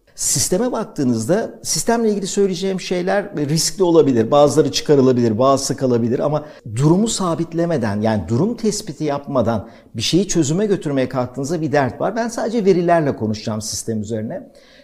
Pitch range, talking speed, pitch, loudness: 125-190 Hz, 135 wpm, 155 Hz, -18 LUFS